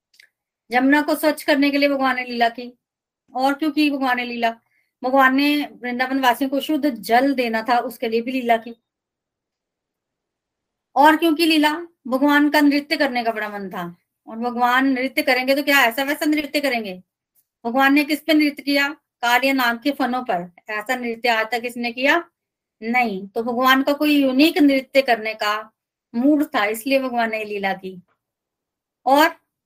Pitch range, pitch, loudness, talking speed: 235-290 Hz, 260 Hz, -19 LUFS, 170 wpm